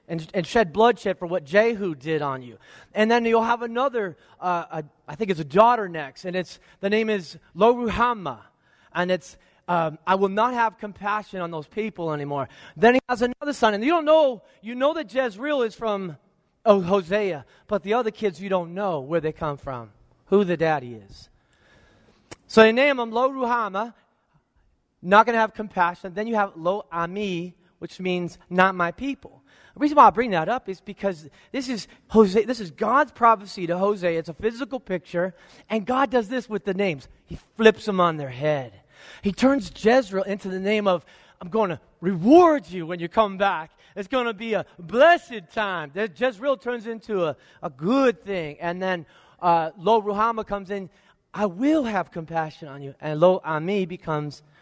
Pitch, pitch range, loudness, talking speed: 200 Hz, 170-225 Hz, -23 LUFS, 190 wpm